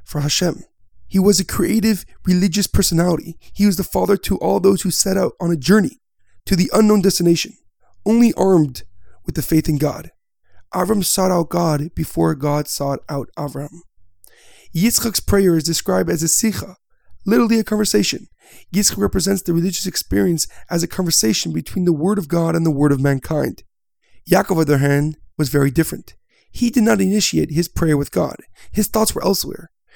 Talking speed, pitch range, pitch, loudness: 180 wpm, 150-195 Hz, 170 Hz, -18 LUFS